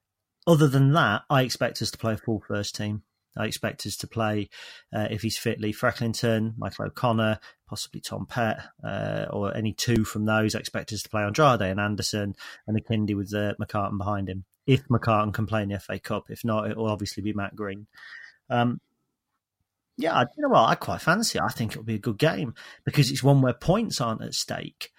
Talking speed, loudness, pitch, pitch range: 220 wpm, -26 LUFS, 110 Hz, 105-125 Hz